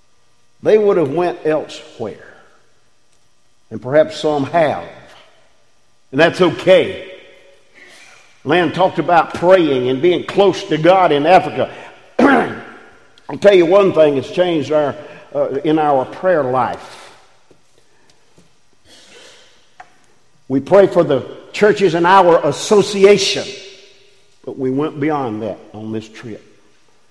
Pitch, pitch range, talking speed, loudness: 170 Hz, 145-195 Hz, 115 wpm, -14 LUFS